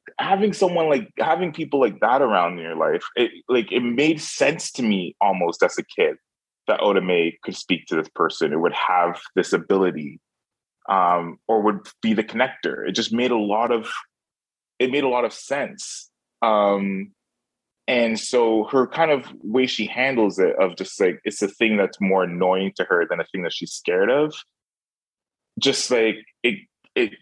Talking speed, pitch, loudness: 185 wpm, 125 Hz, -21 LUFS